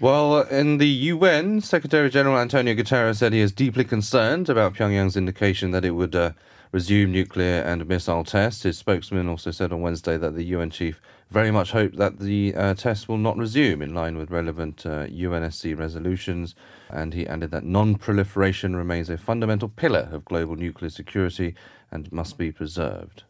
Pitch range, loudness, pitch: 85-110 Hz, -23 LUFS, 95 Hz